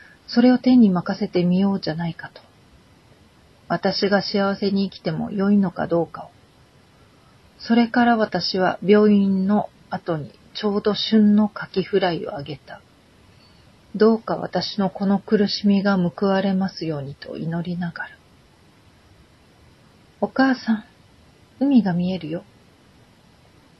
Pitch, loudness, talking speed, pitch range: 195 Hz, -21 LUFS, 240 characters per minute, 175-210 Hz